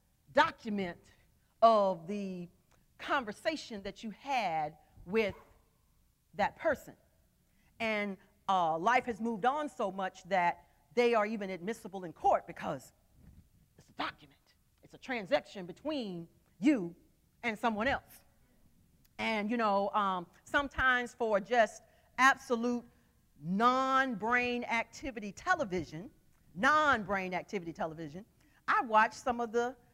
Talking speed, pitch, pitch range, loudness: 115 wpm, 220 Hz, 185-245 Hz, -33 LUFS